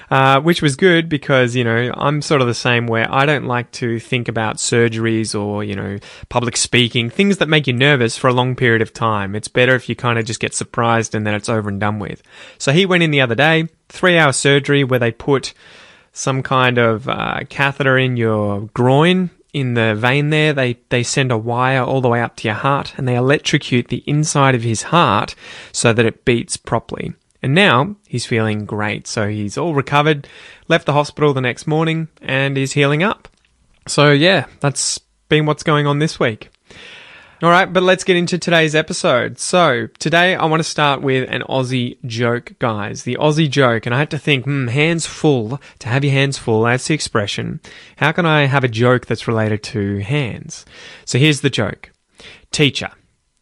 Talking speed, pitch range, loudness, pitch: 205 wpm, 115-150 Hz, -16 LUFS, 130 Hz